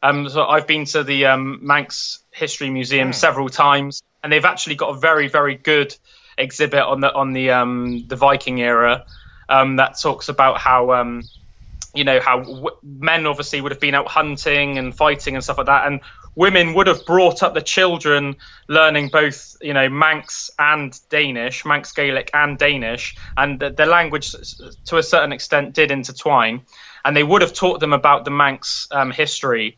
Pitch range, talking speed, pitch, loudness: 130-150 Hz, 185 wpm, 140 Hz, -17 LUFS